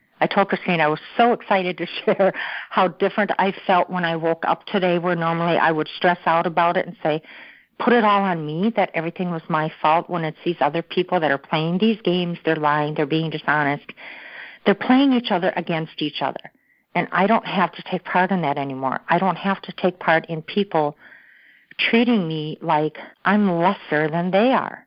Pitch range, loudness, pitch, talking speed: 160-195 Hz, -21 LUFS, 175 Hz, 205 wpm